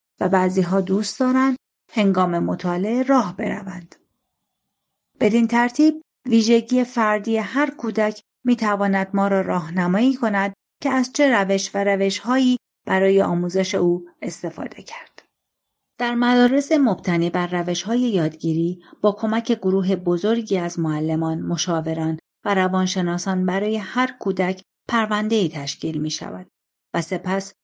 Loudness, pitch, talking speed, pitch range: -21 LUFS, 195 Hz, 130 wpm, 180-230 Hz